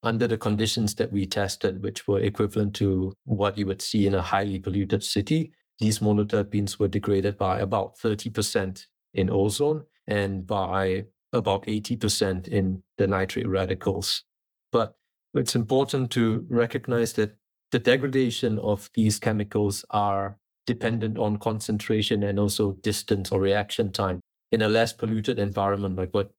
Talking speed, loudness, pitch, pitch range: 145 wpm, -26 LUFS, 105 Hz, 100-115 Hz